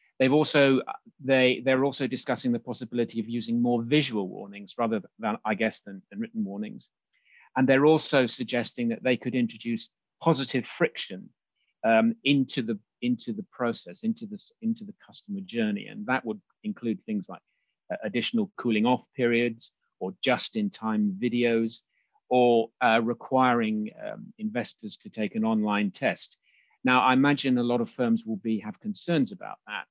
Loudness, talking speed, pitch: -27 LUFS, 160 wpm, 130 Hz